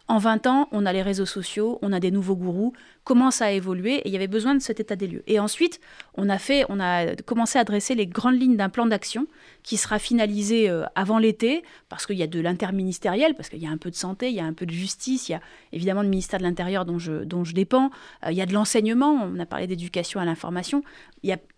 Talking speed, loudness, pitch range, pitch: 265 wpm, -24 LUFS, 185-240 Hz, 205 Hz